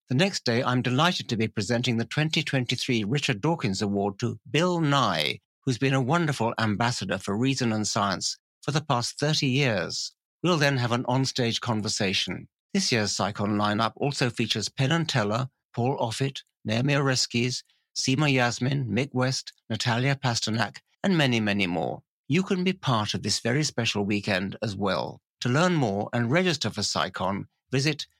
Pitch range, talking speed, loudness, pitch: 110-140 Hz, 165 wpm, -26 LUFS, 125 Hz